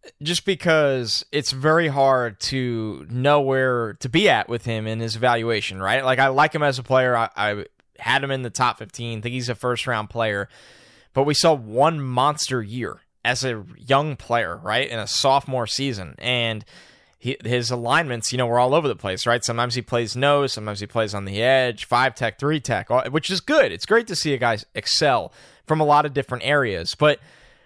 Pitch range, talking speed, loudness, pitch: 115-145 Hz, 210 wpm, -21 LUFS, 125 Hz